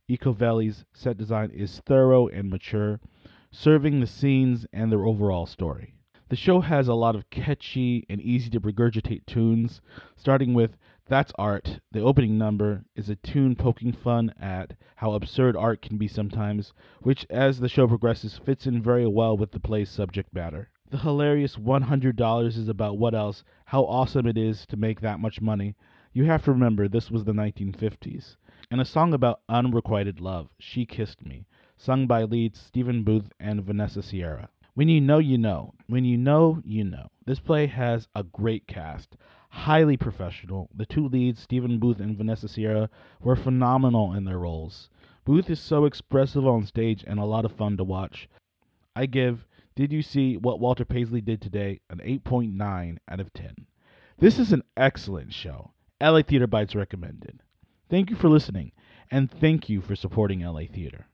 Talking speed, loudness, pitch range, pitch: 175 wpm, -25 LUFS, 105-130 Hz, 115 Hz